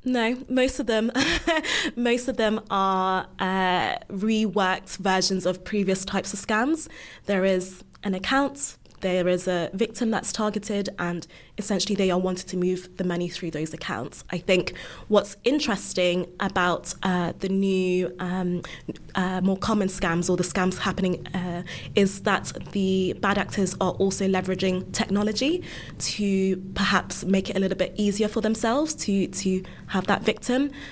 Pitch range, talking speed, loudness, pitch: 185-215 Hz, 155 wpm, -25 LUFS, 190 Hz